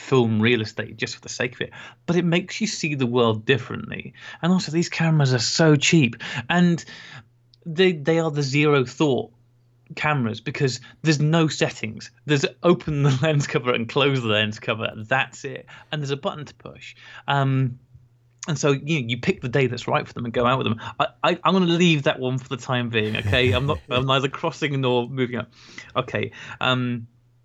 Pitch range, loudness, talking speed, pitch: 120-155 Hz, -22 LUFS, 210 wpm, 130 Hz